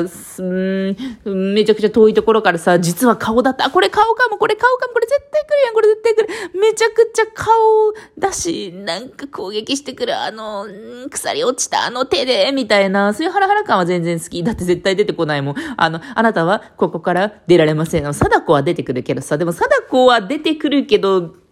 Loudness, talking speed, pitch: -16 LUFS, 395 characters per minute, 225 Hz